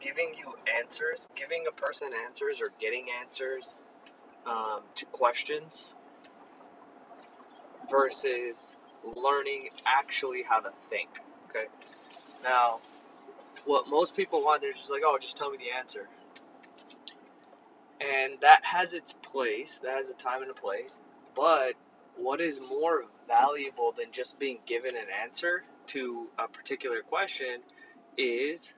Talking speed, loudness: 125 wpm, -30 LUFS